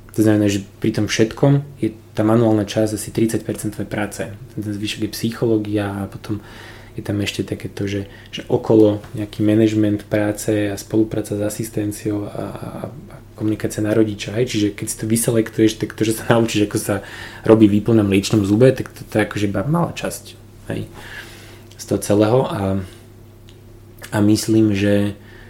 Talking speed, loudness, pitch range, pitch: 170 wpm, -19 LUFS, 105-115 Hz, 110 Hz